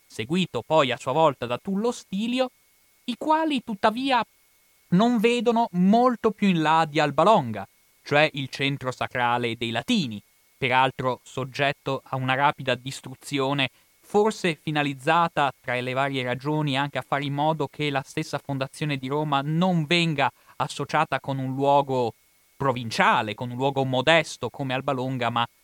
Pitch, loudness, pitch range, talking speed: 140 Hz, -24 LUFS, 130-170 Hz, 145 wpm